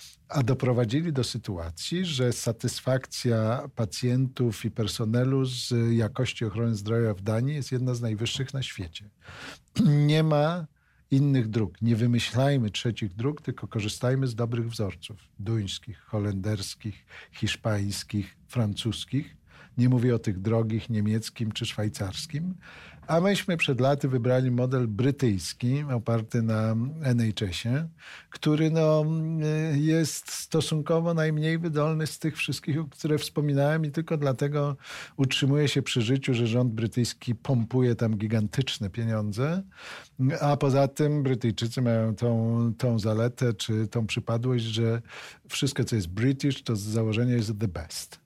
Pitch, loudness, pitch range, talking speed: 125 Hz, -27 LUFS, 115-140 Hz, 130 wpm